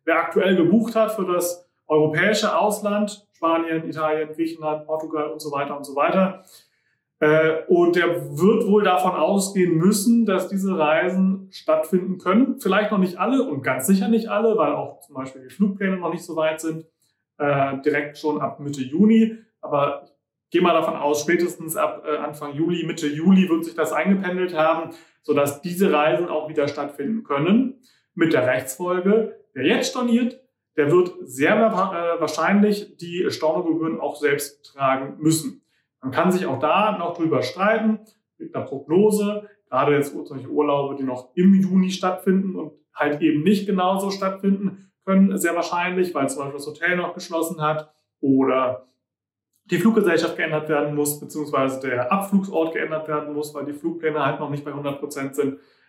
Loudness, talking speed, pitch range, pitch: -21 LUFS, 165 wpm, 150-195 Hz, 165 Hz